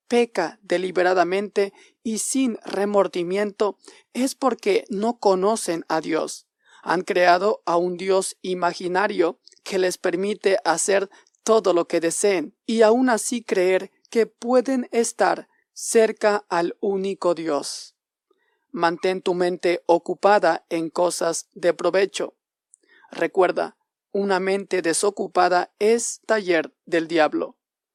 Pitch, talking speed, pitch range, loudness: 195 Hz, 110 wpm, 175-220 Hz, -22 LUFS